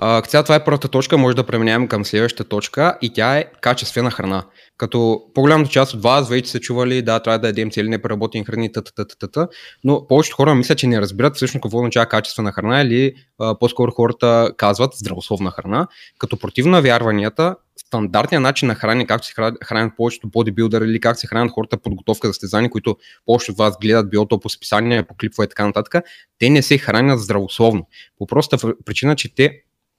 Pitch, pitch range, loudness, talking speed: 115 Hz, 110-130 Hz, -17 LUFS, 190 wpm